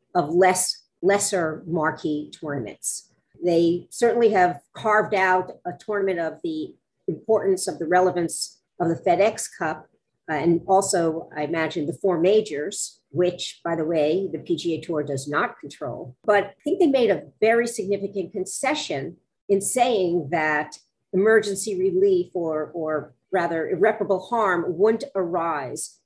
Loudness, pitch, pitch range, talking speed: -23 LUFS, 180 Hz, 165-205 Hz, 140 wpm